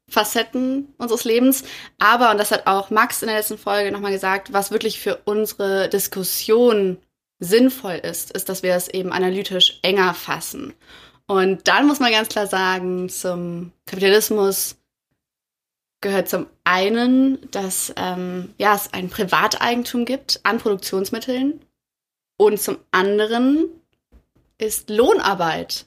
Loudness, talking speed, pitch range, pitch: -19 LUFS, 130 wpm, 190-235 Hz, 205 Hz